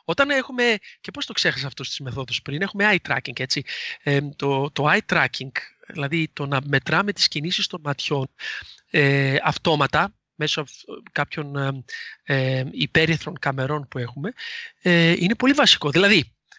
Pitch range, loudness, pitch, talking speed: 140-190 Hz, -22 LUFS, 150 Hz, 150 wpm